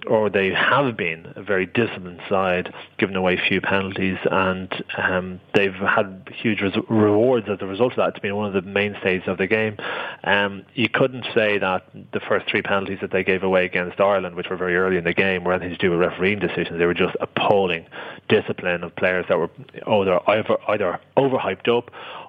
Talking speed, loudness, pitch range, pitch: 200 wpm, -21 LUFS, 90-105 Hz, 95 Hz